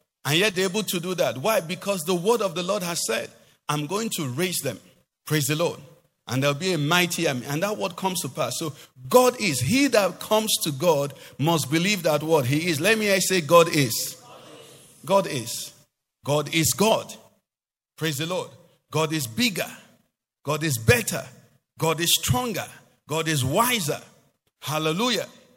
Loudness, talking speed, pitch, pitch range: -23 LUFS, 180 wpm, 160 Hz, 145-185 Hz